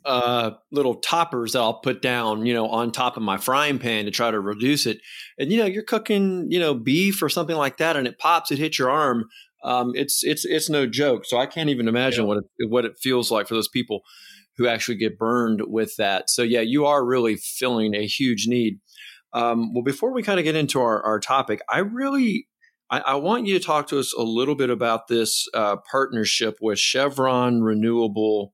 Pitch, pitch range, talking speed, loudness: 125 Hz, 115-150 Hz, 220 wpm, -22 LUFS